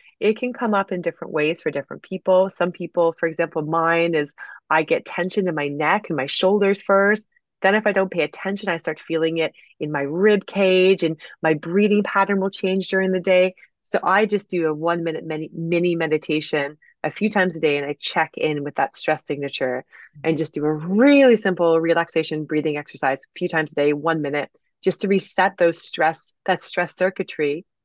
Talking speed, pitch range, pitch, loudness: 205 wpm, 155-190 Hz, 170 Hz, -21 LUFS